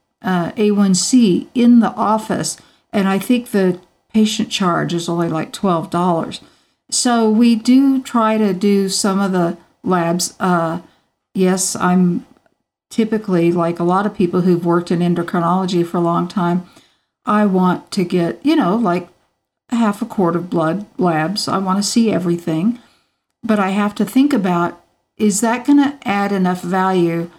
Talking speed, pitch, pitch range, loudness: 160 wpm, 190 Hz, 175-220 Hz, -16 LUFS